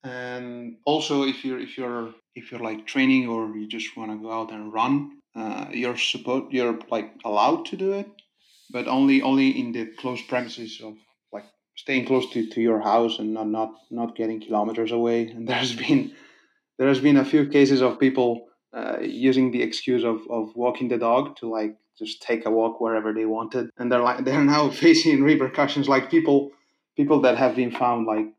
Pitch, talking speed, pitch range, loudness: 125 Hz, 200 wpm, 115-140 Hz, -23 LUFS